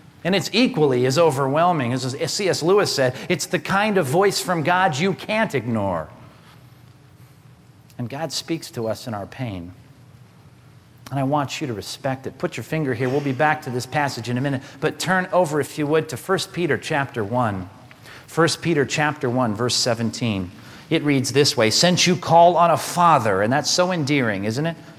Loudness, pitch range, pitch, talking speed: -20 LUFS, 125-165 Hz, 140 Hz, 190 wpm